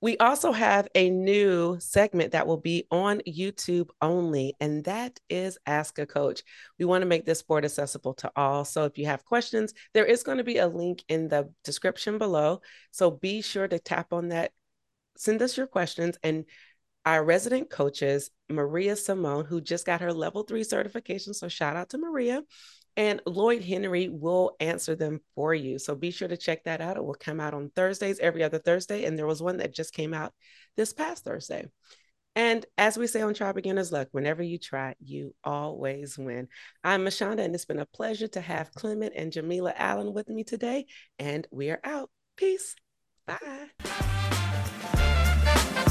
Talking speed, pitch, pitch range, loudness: 185 wpm, 175 Hz, 155-210 Hz, -28 LUFS